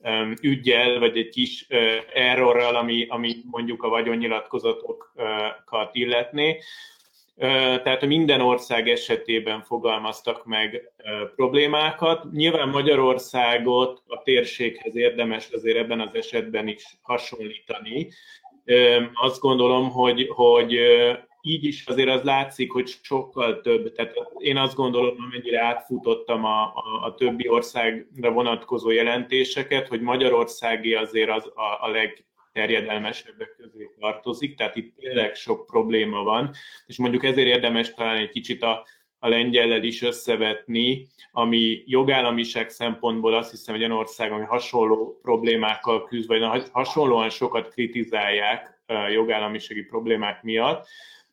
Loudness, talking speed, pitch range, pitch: -22 LUFS, 115 wpm, 115-135 Hz, 120 Hz